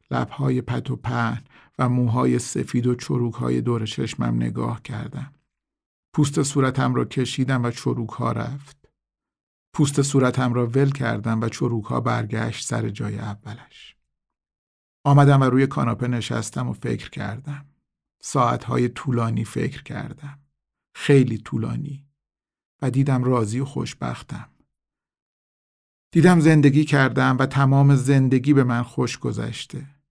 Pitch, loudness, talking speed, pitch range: 130 Hz, -22 LUFS, 125 wpm, 115-140 Hz